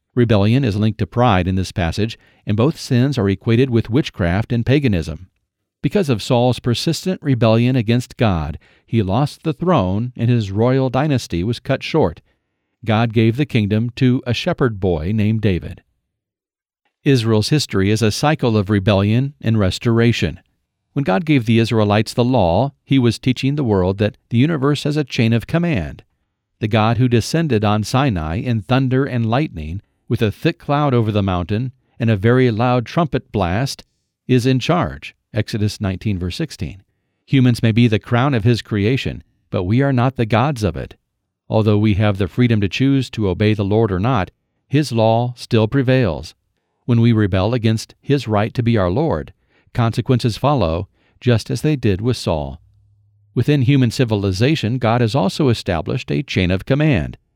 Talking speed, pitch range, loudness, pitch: 170 wpm, 105-130 Hz, -17 LUFS, 115 Hz